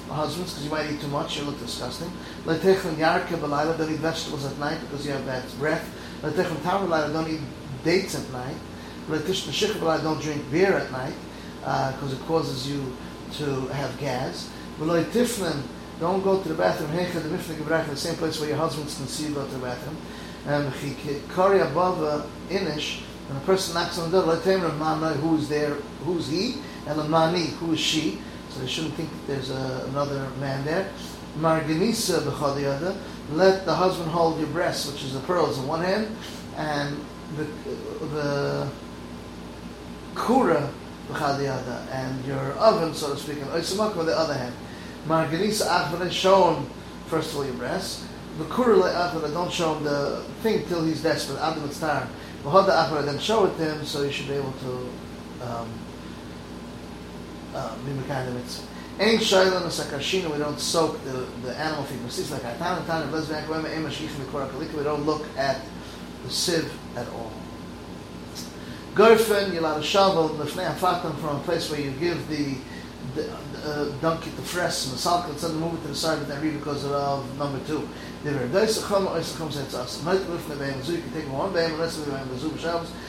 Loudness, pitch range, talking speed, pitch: -26 LUFS, 140-170 Hz, 175 wpm, 155 Hz